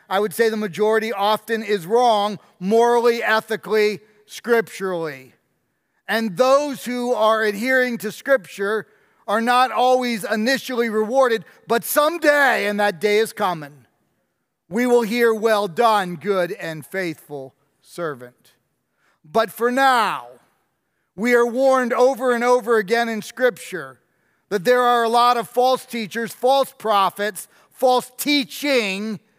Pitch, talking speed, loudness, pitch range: 225 Hz, 130 wpm, -19 LUFS, 205-245 Hz